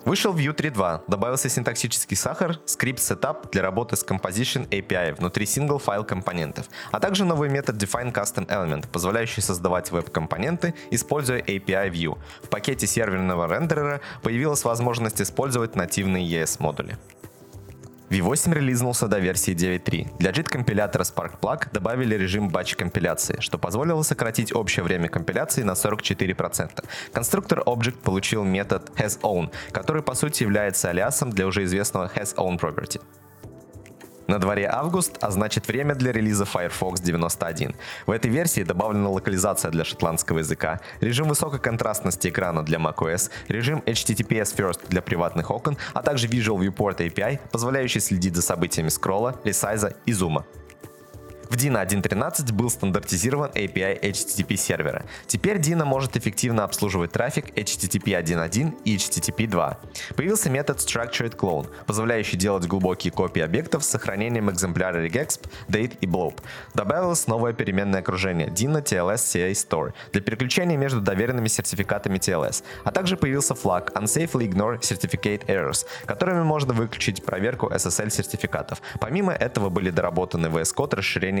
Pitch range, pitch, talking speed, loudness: 95-130 Hz, 110 Hz, 140 wpm, -24 LUFS